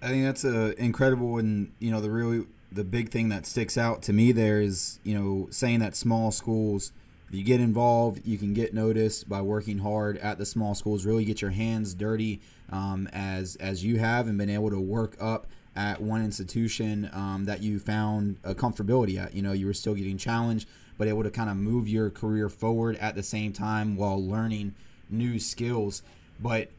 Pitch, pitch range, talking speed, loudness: 105 Hz, 100-115 Hz, 205 wpm, -28 LUFS